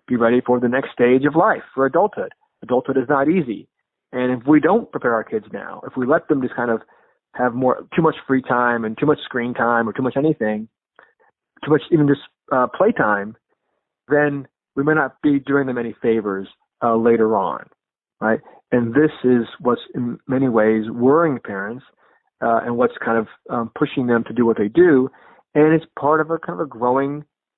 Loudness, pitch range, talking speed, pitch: -19 LUFS, 120-150 Hz, 205 wpm, 130 Hz